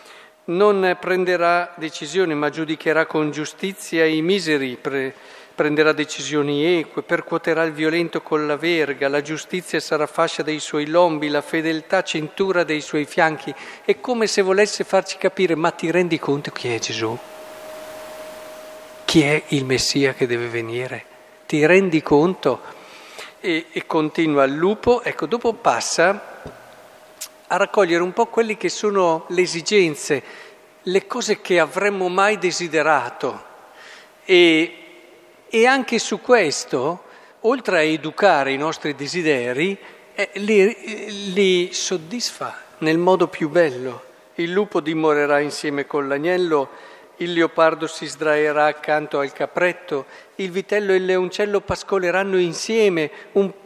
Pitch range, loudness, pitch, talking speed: 155-195 Hz, -20 LUFS, 170 Hz, 130 wpm